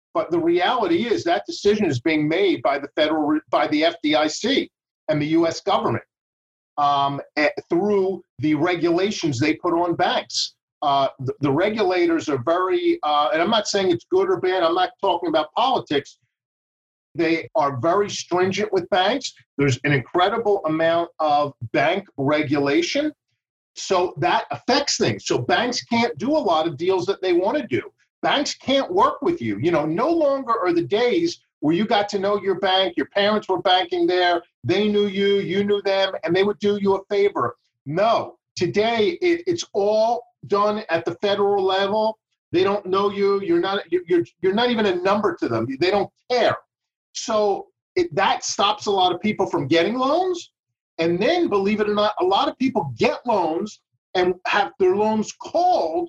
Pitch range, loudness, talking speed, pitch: 165-255 Hz, -21 LUFS, 185 wpm, 200 Hz